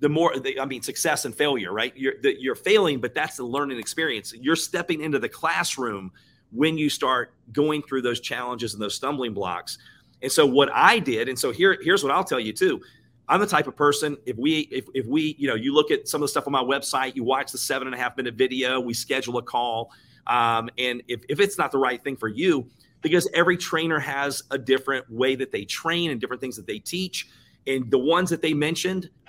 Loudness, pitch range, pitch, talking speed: -24 LUFS, 125-170 Hz, 140 Hz, 235 wpm